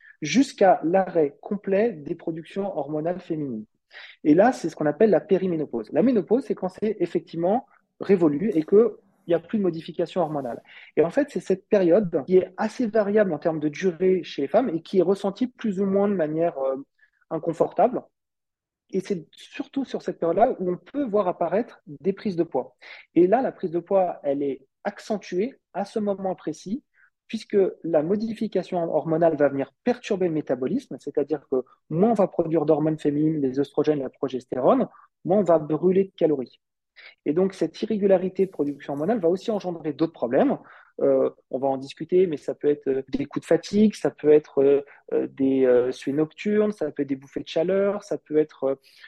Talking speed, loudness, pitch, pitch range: 195 wpm, -24 LUFS, 175 Hz, 150-200 Hz